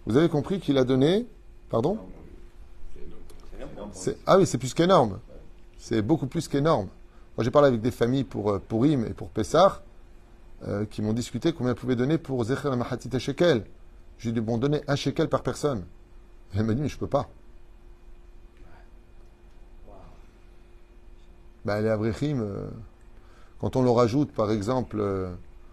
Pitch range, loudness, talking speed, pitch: 100-135 Hz, -26 LUFS, 150 wpm, 115 Hz